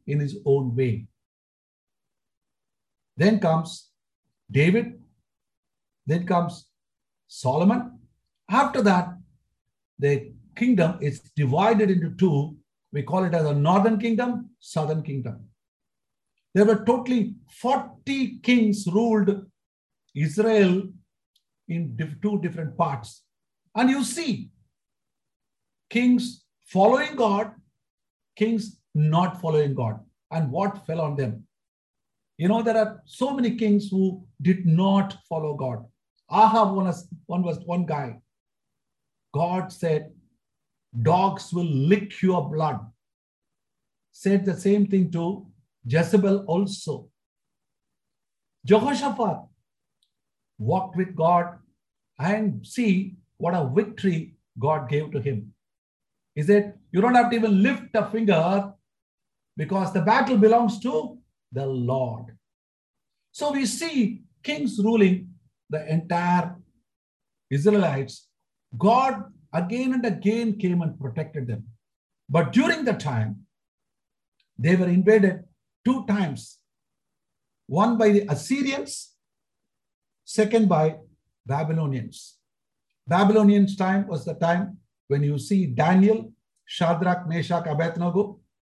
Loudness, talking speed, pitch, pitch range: -23 LUFS, 110 wpm, 180 Hz, 150-210 Hz